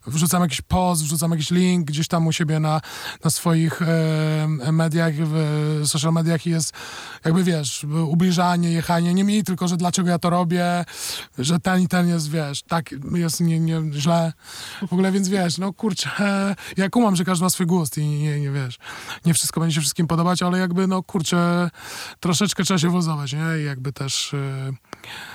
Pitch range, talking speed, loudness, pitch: 155-180 Hz, 185 wpm, -21 LUFS, 170 Hz